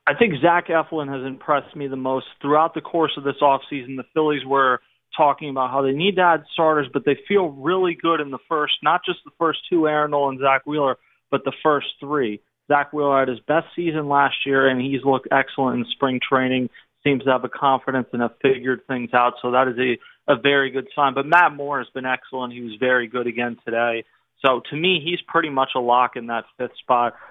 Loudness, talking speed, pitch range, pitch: -21 LUFS, 230 wpm, 130-150 Hz, 135 Hz